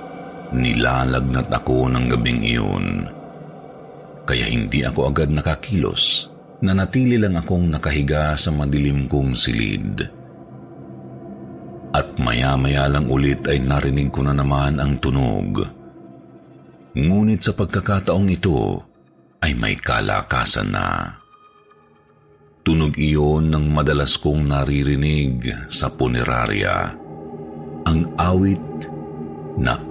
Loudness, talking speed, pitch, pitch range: -19 LUFS, 100 wpm, 75 Hz, 65-80 Hz